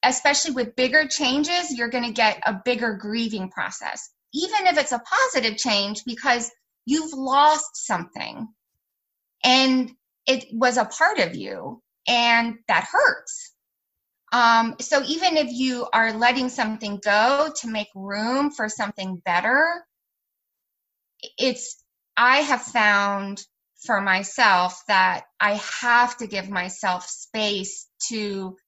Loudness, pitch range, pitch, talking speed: -21 LUFS, 210-270 Hz, 240 Hz, 130 wpm